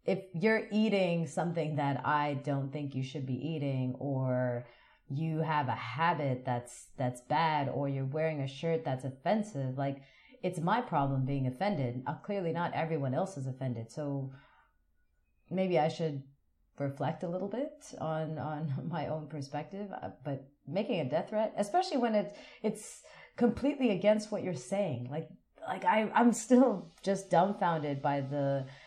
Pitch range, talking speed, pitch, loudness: 135-195 Hz, 160 wpm, 155 Hz, -33 LUFS